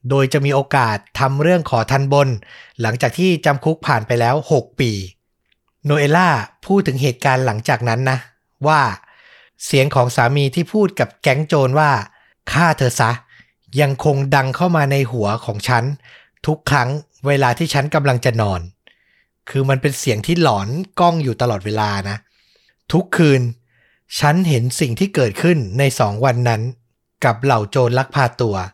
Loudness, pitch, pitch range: -17 LUFS, 135 Hz, 120-150 Hz